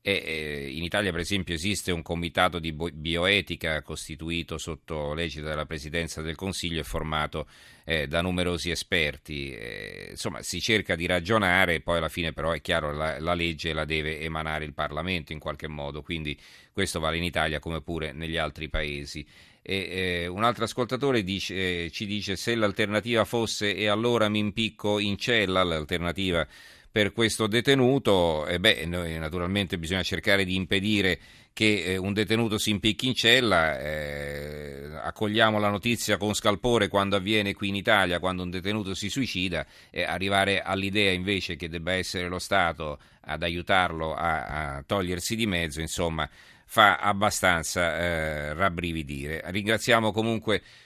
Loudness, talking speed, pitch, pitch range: -26 LUFS, 160 wpm, 90 Hz, 80-100 Hz